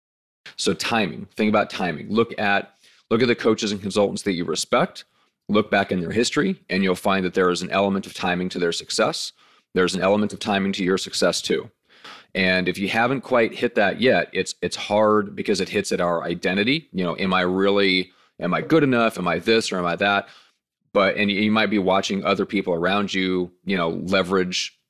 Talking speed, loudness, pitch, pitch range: 215 wpm, -22 LUFS, 100 Hz, 90-105 Hz